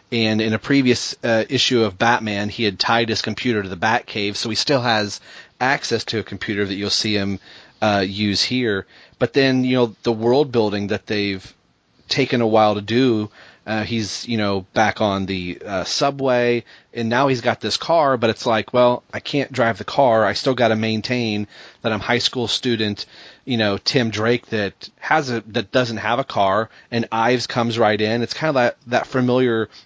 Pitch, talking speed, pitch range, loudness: 115 Hz, 205 wpm, 105-125 Hz, -19 LUFS